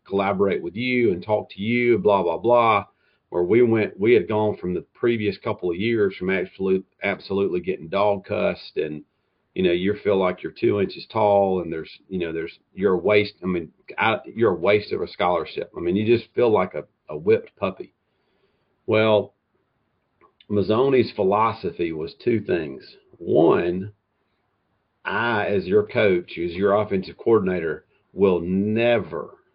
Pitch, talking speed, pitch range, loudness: 100 Hz, 165 wpm, 95-110 Hz, -22 LUFS